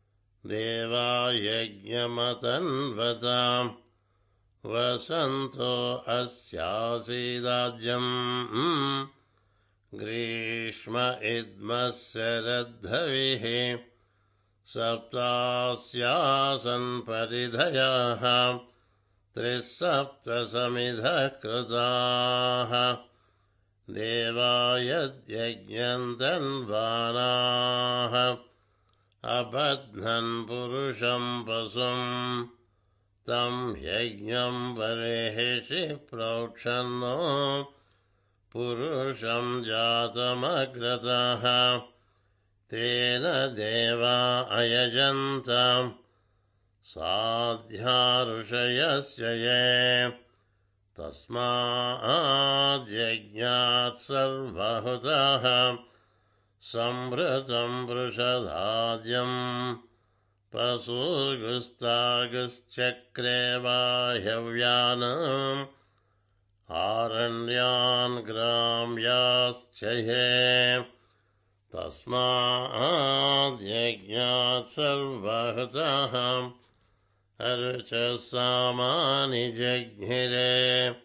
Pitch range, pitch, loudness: 115-125 Hz, 120 Hz, -27 LUFS